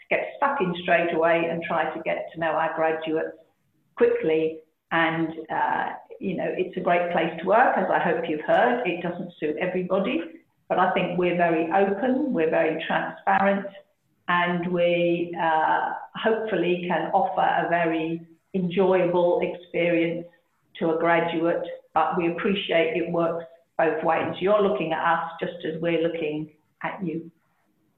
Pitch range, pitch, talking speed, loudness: 160-185 Hz, 170 Hz, 155 wpm, -24 LUFS